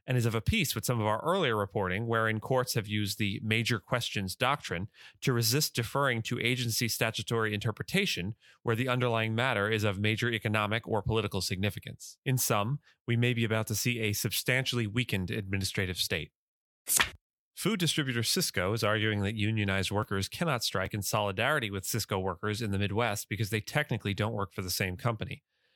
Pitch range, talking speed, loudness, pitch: 105-125 Hz, 180 wpm, -30 LUFS, 110 Hz